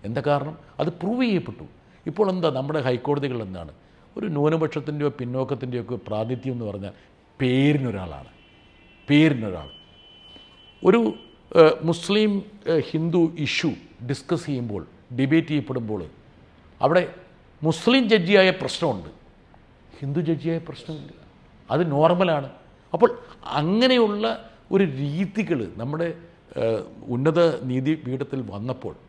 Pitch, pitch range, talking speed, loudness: 145 Hz, 125-170 Hz, 90 wpm, -23 LUFS